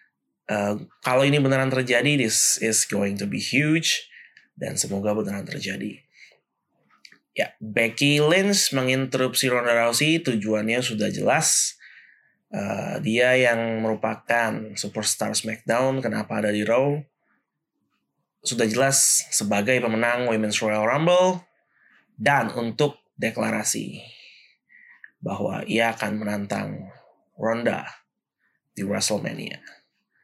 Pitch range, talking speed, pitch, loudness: 110-135 Hz, 100 wpm, 115 Hz, -22 LUFS